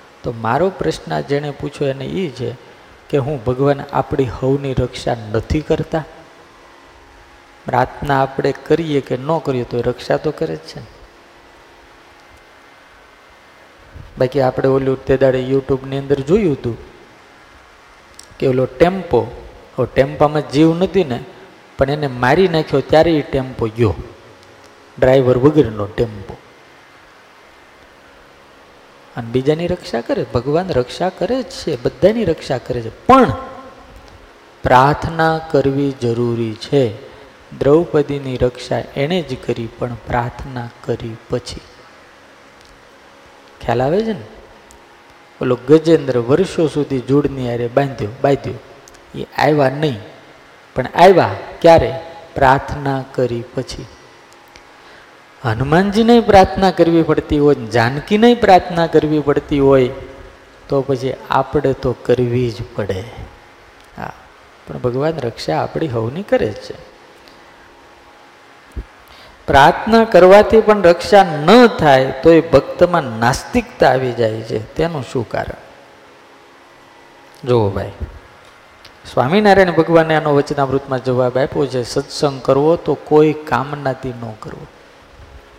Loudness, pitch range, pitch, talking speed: -15 LUFS, 110-150 Hz, 130 Hz, 115 wpm